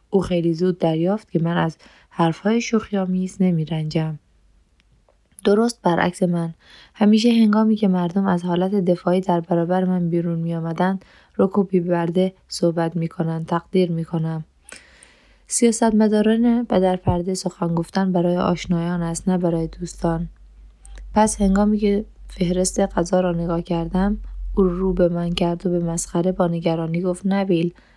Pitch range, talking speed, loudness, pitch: 170-195 Hz, 150 wpm, -21 LUFS, 180 Hz